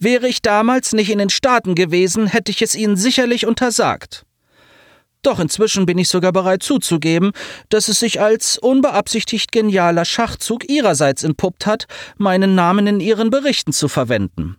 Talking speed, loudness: 155 wpm, -15 LUFS